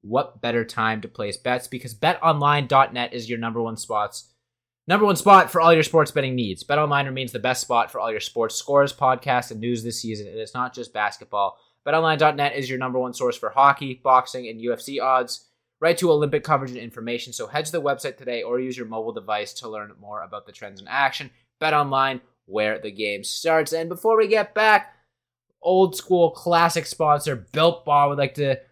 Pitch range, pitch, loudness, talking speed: 120-155 Hz, 130 Hz, -22 LUFS, 205 wpm